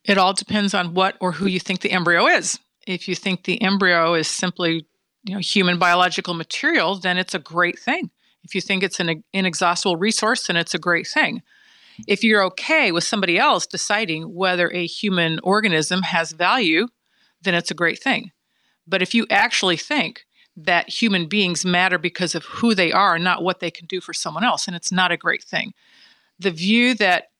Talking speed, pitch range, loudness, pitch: 195 wpm, 175-210 Hz, -19 LUFS, 185 Hz